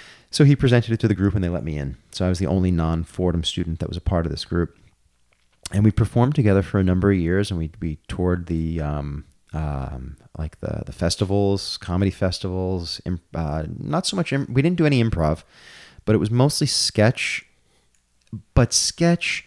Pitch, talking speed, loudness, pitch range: 95 Hz, 205 wpm, -22 LUFS, 80-110 Hz